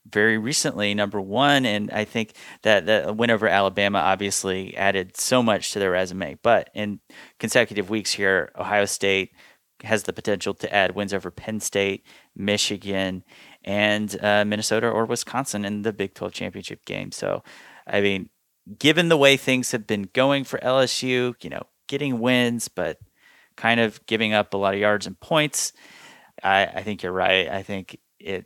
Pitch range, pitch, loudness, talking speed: 100-115 Hz, 105 Hz, -22 LUFS, 175 wpm